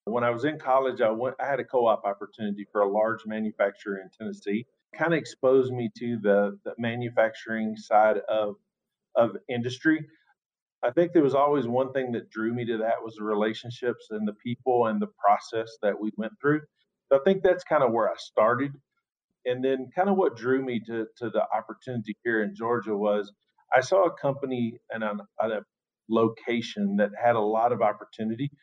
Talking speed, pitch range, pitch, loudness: 195 wpm, 110-130 Hz, 120 Hz, -27 LUFS